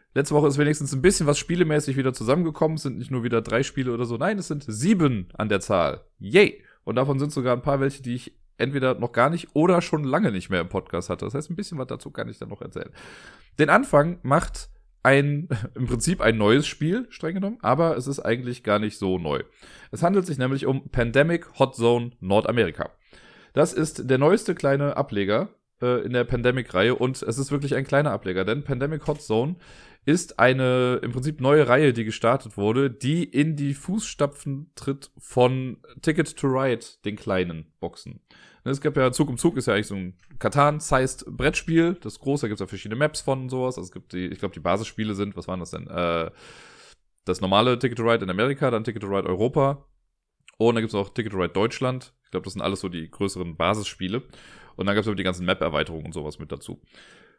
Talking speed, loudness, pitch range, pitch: 220 wpm, -24 LUFS, 110-145 Hz, 130 Hz